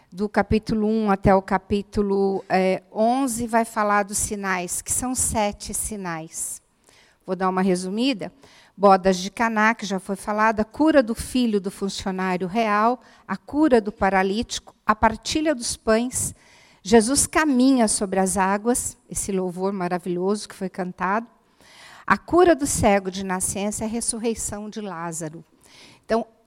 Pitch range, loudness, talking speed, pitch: 190-230 Hz, -22 LUFS, 145 wpm, 210 Hz